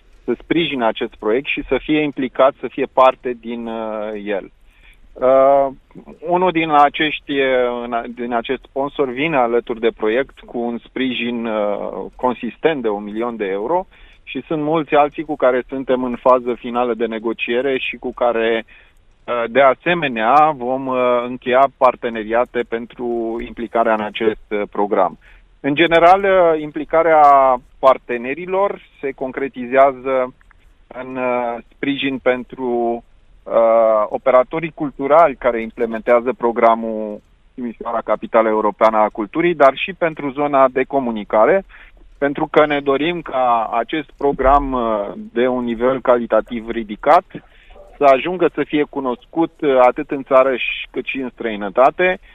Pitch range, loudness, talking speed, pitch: 115-140 Hz, -17 LUFS, 130 wpm, 125 Hz